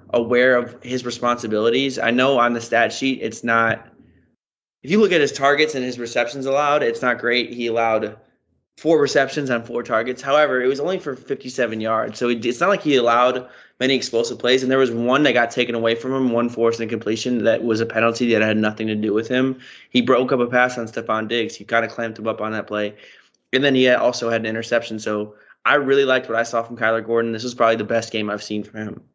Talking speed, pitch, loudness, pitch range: 240 wpm, 120 Hz, -20 LUFS, 115-130 Hz